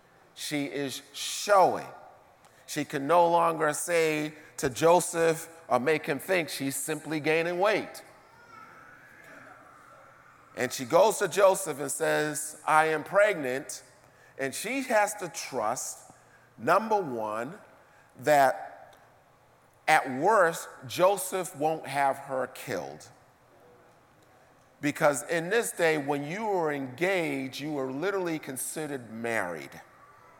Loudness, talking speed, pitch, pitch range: -28 LUFS, 110 wpm, 155 Hz, 140-175 Hz